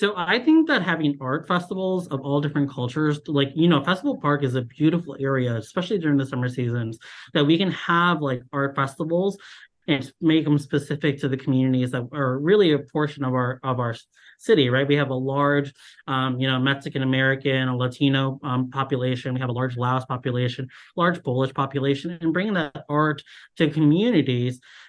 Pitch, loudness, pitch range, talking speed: 140 Hz, -23 LUFS, 130-160 Hz, 190 wpm